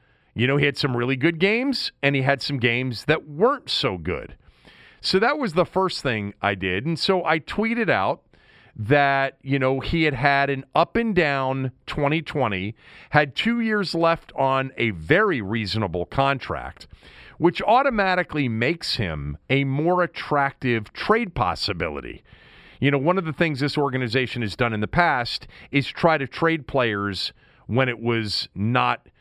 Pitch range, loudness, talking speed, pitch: 120-165 Hz, -22 LUFS, 165 wpm, 140 Hz